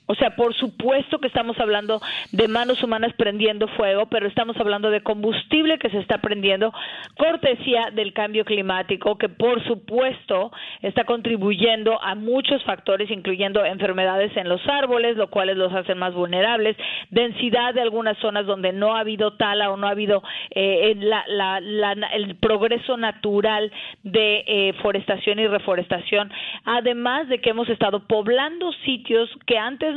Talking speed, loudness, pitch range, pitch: 160 wpm, -21 LUFS, 205-235 Hz, 220 Hz